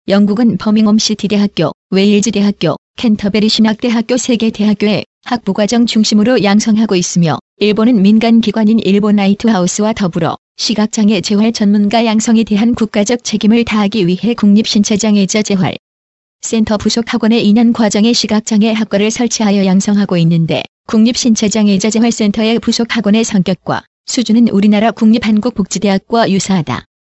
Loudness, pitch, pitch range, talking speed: -11 LUFS, 215 Hz, 200-225 Hz, 380 characters per minute